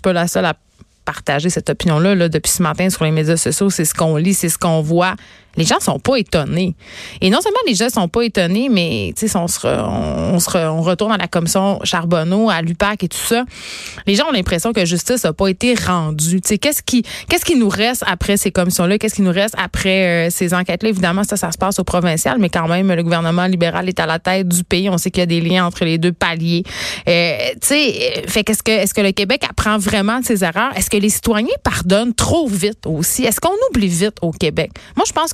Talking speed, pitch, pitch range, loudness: 245 wpm, 185 Hz, 175-215 Hz, -16 LUFS